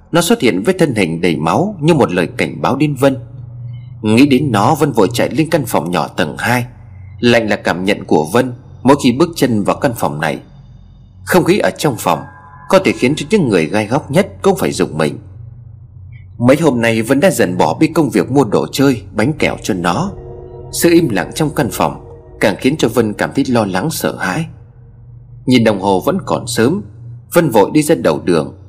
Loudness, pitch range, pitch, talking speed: -14 LUFS, 110-145 Hz, 120 Hz, 220 wpm